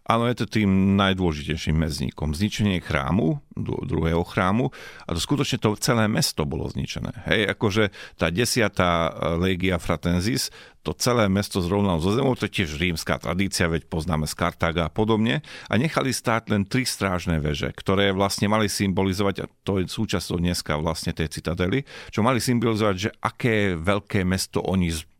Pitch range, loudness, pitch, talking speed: 85-110 Hz, -24 LUFS, 95 Hz, 160 wpm